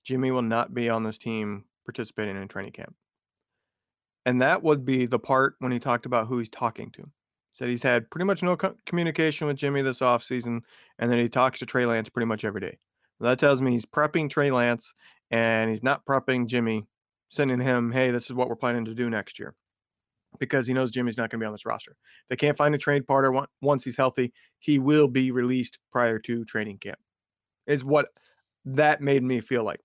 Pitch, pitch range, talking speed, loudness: 125 Hz, 115-135 Hz, 220 wpm, -26 LUFS